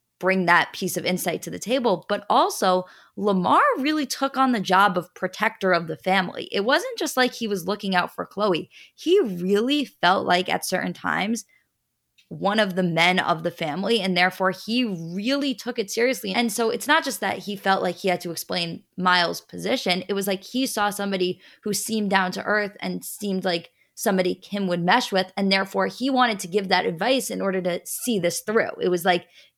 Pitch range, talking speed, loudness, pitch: 180-230 Hz, 210 wpm, -23 LUFS, 195 Hz